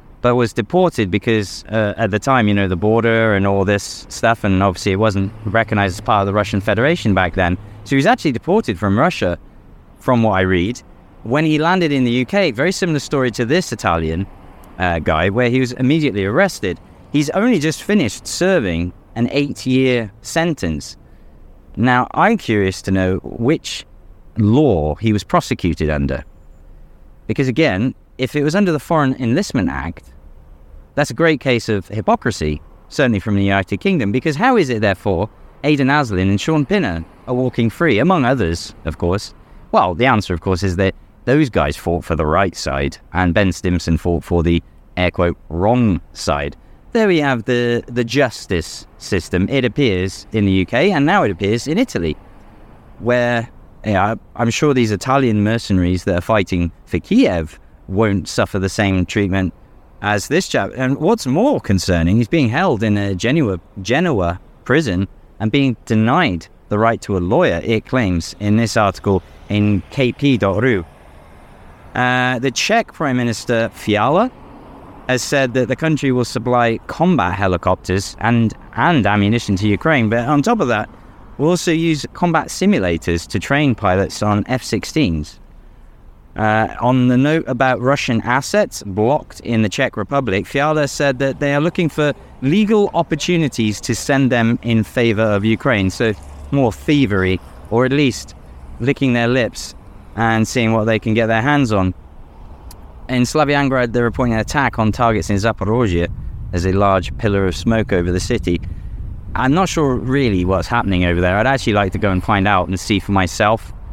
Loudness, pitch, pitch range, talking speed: -17 LUFS, 110 Hz, 90-130 Hz, 170 wpm